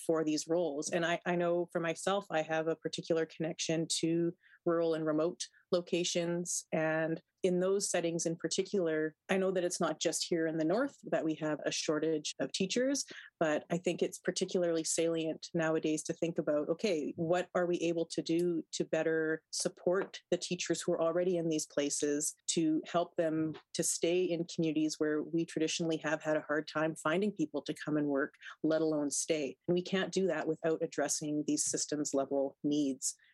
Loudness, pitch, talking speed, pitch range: -34 LUFS, 165 Hz, 190 wpm, 155-175 Hz